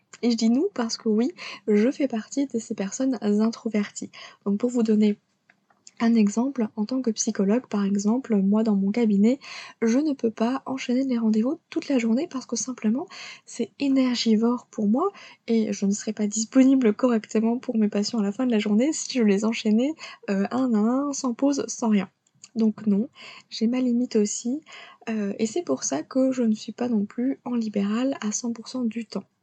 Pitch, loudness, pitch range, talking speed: 230 Hz, -24 LUFS, 215-255 Hz, 200 wpm